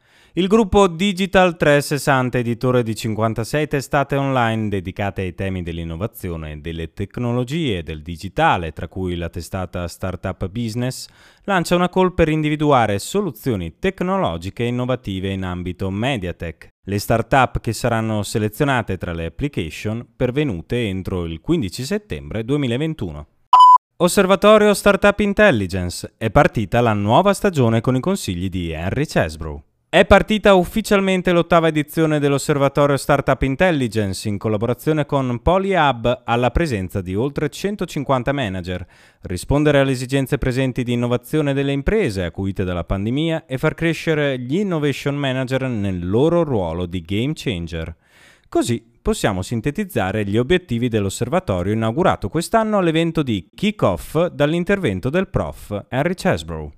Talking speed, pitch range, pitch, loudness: 130 wpm, 100-155 Hz, 125 Hz, -19 LUFS